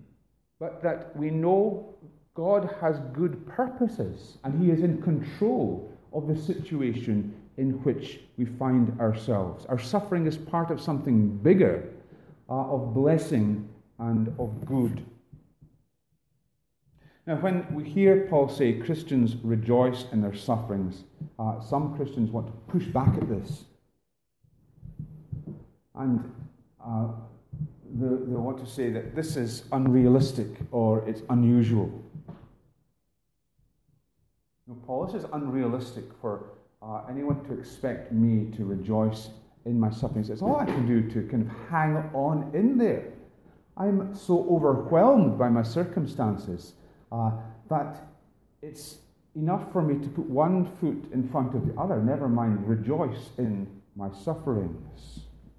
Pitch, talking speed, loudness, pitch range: 130 Hz, 135 wpm, -27 LUFS, 115-155 Hz